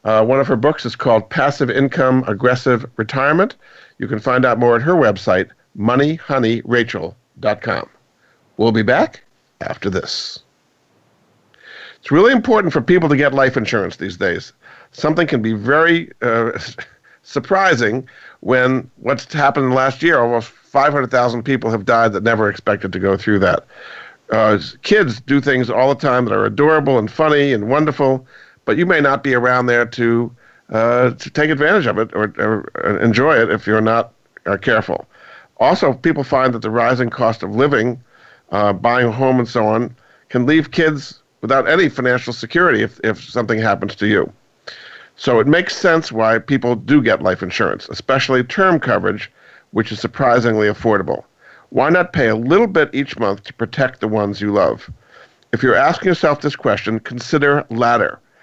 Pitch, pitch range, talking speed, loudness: 125 Hz, 115-140 Hz, 170 wpm, -16 LUFS